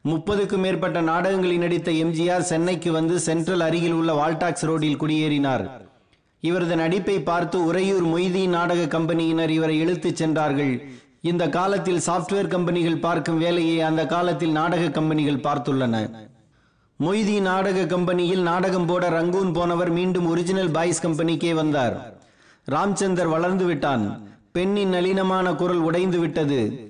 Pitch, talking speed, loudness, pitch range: 170 Hz, 120 wpm, -22 LUFS, 160-180 Hz